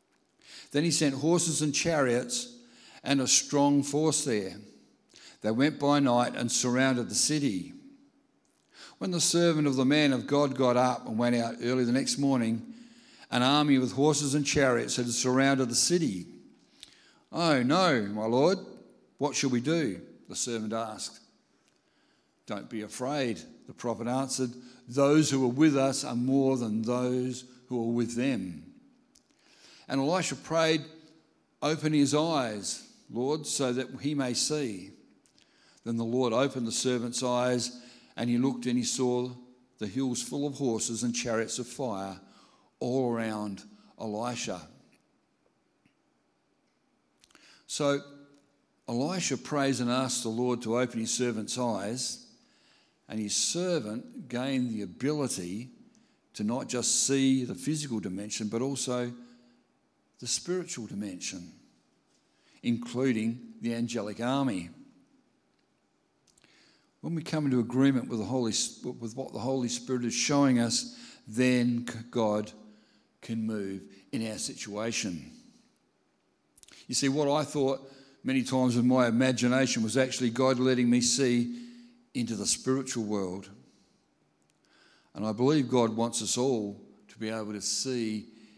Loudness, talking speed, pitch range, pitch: -29 LUFS, 140 wpm, 120-145 Hz, 125 Hz